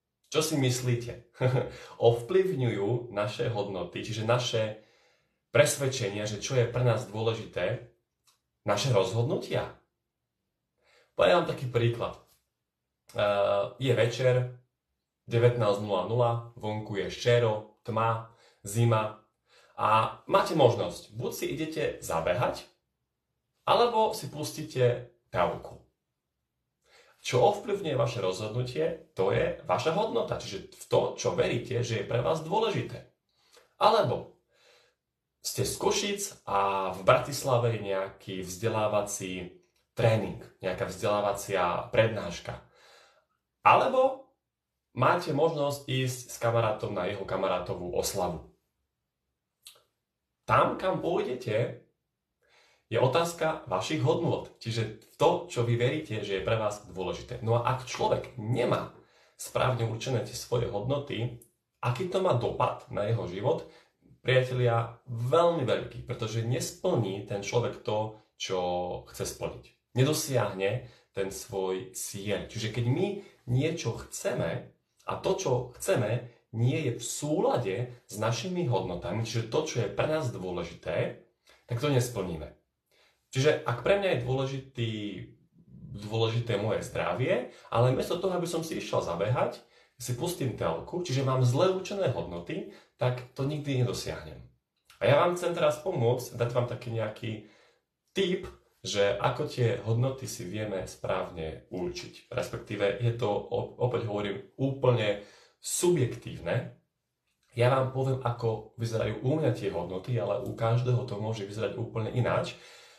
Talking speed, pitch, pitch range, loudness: 120 wpm, 120 Hz, 105-130 Hz, -30 LUFS